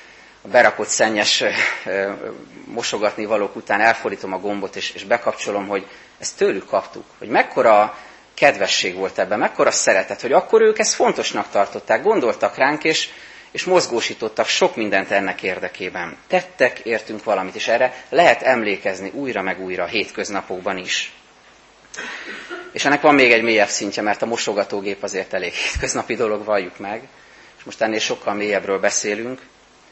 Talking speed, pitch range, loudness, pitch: 150 wpm, 100-130 Hz, -19 LUFS, 105 Hz